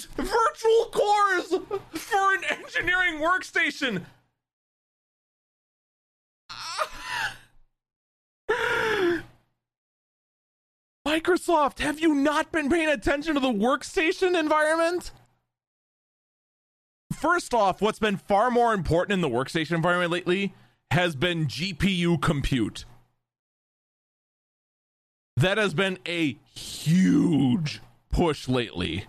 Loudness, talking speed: -25 LUFS, 85 wpm